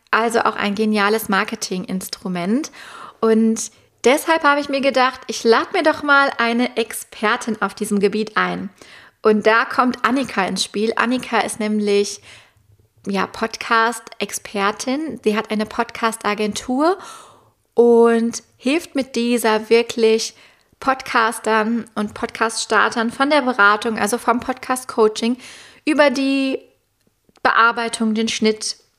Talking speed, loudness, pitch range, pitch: 115 wpm, -18 LUFS, 215-255 Hz, 230 Hz